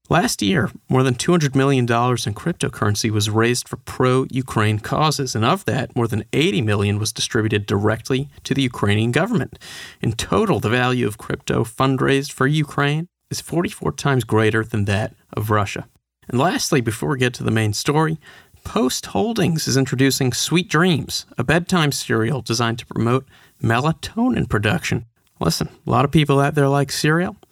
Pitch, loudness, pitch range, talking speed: 130 Hz, -20 LUFS, 110-145 Hz, 170 wpm